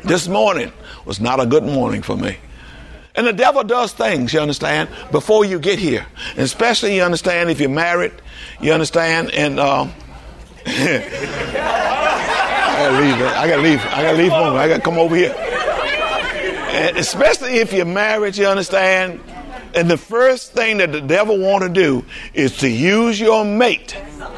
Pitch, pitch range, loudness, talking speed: 185 Hz, 160-215 Hz, -16 LUFS, 160 wpm